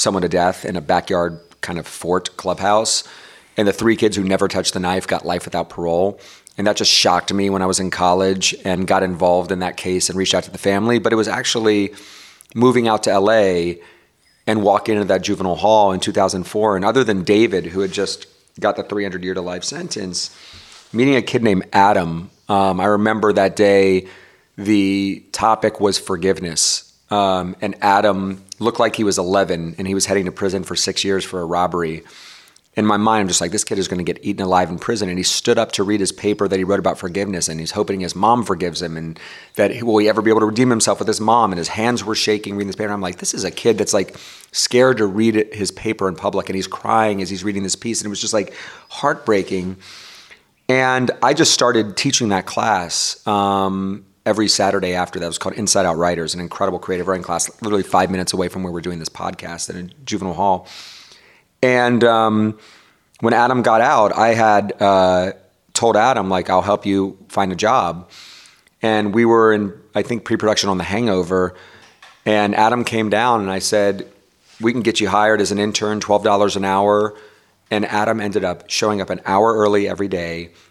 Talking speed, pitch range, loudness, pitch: 215 wpm, 90-105 Hz, -17 LUFS, 100 Hz